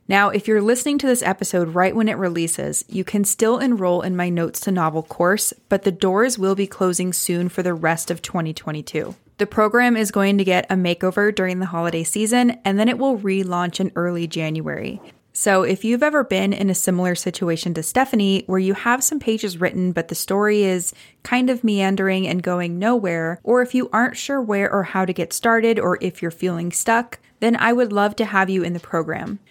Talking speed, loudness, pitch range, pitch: 215 wpm, -20 LUFS, 180-220 Hz, 195 Hz